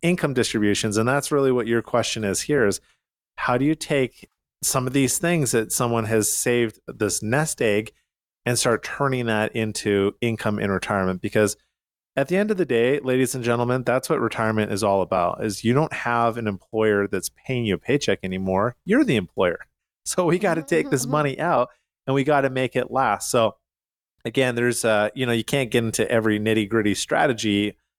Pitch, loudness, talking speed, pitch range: 120 Hz, -22 LUFS, 200 wpm, 110-135 Hz